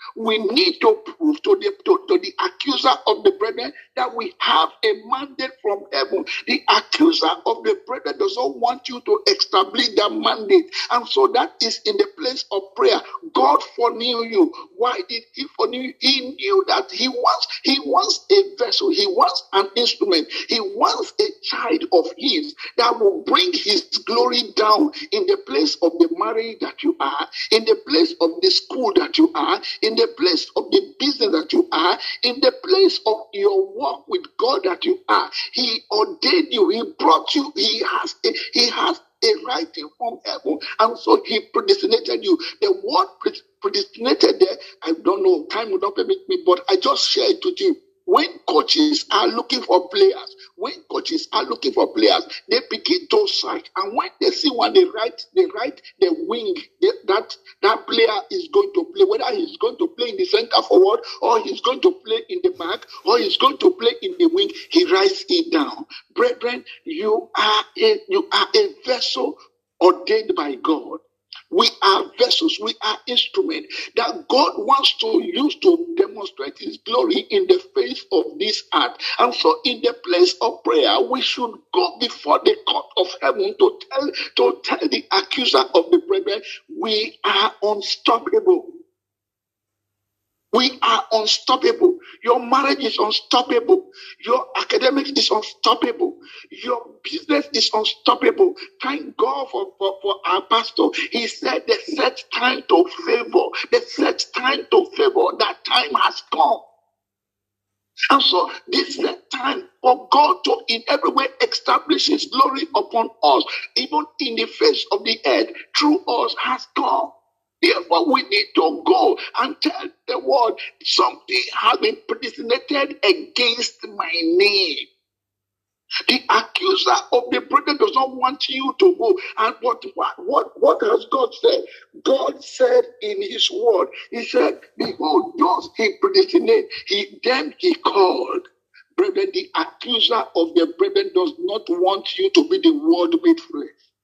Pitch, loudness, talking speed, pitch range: 370 Hz, -19 LUFS, 170 wpm, 315-400 Hz